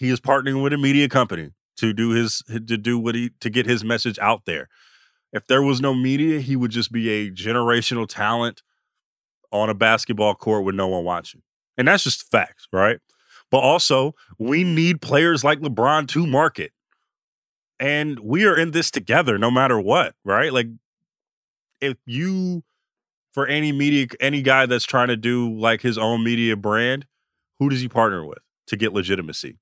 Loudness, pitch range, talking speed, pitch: -20 LUFS, 115-140 Hz, 180 wpm, 120 Hz